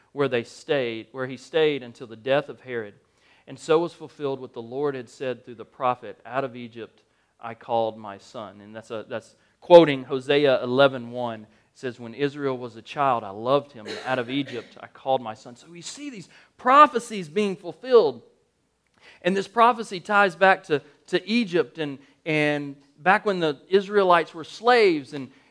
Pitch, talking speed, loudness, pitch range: 140 Hz, 190 wpm, -23 LUFS, 125-170 Hz